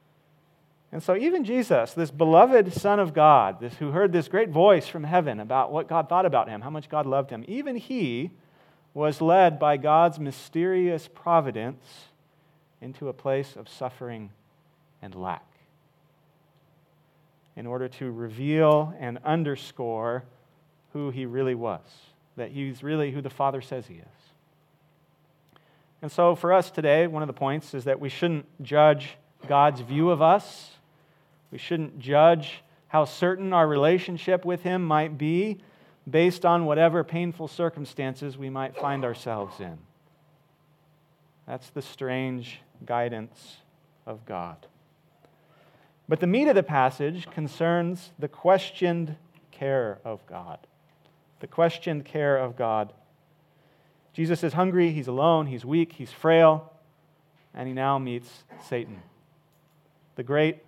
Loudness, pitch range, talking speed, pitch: -25 LUFS, 135-165 Hz, 140 wpm, 155 Hz